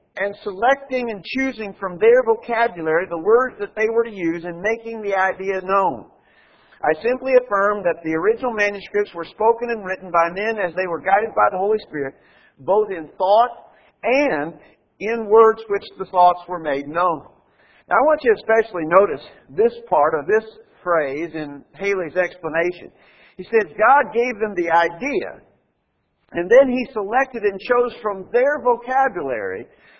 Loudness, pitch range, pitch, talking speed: -19 LUFS, 180-245 Hz, 210 Hz, 165 wpm